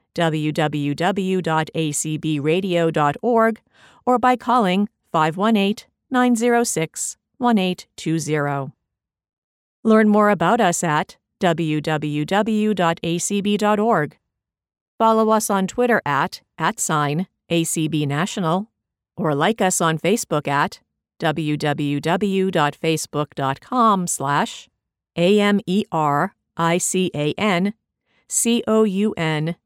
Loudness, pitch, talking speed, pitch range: -20 LUFS, 175 Hz, 80 wpm, 155-215 Hz